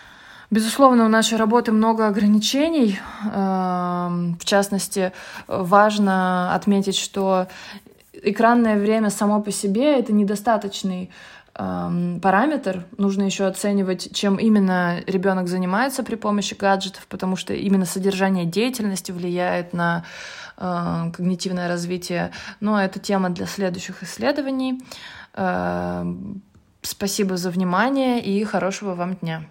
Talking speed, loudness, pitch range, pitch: 105 wpm, -21 LUFS, 185-215 Hz, 195 Hz